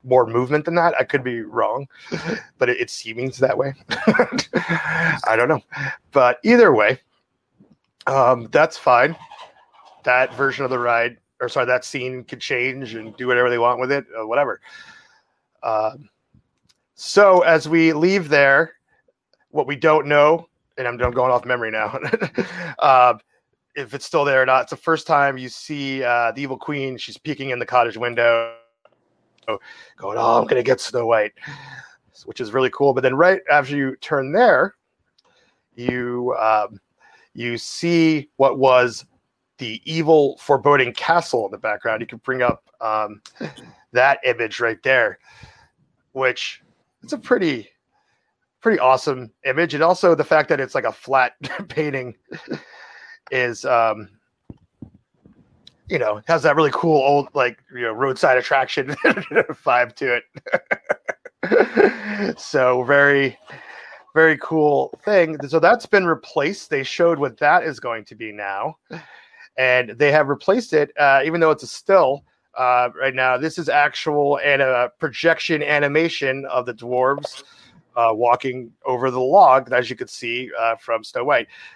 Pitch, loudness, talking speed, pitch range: 135 Hz, -19 LUFS, 160 wpm, 125-155 Hz